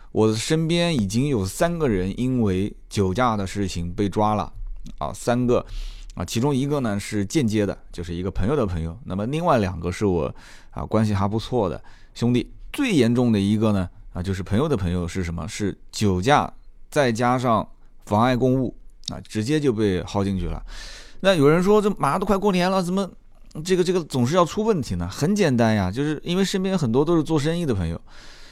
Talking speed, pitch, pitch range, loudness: 295 characters per minute, 115 Hz, 95-150 Hz, -22 LUFS